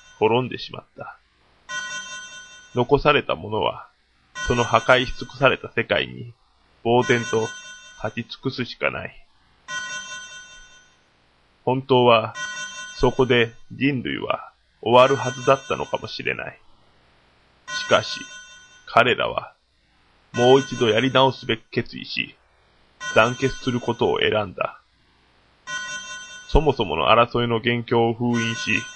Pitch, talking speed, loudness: 135 Hz, 220 characters per minute, -22 LUFS